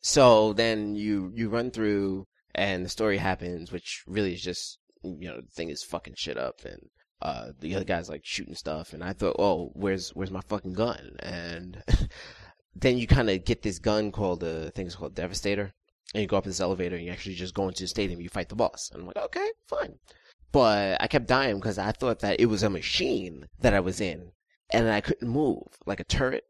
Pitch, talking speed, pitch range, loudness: 100 Hz, 225 wpm, 90-110 Hz, -28 LUFS